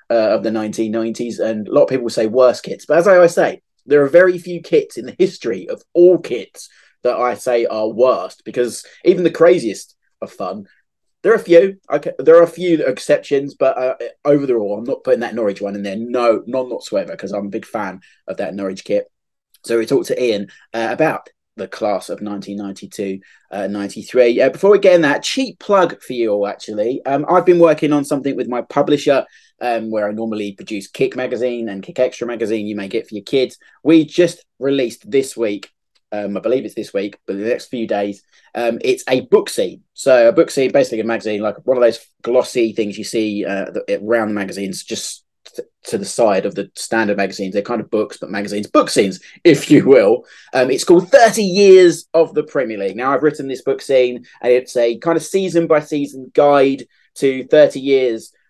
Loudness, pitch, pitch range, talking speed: -16 LUFS, 130 Hz, 110-170 Hz, 215 wpm